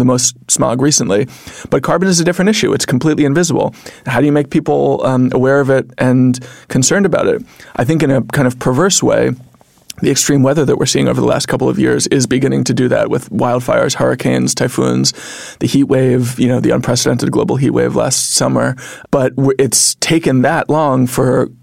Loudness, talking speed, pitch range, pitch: -13 LUFS, 205 wpm, 125-150 Hz, 130 Hz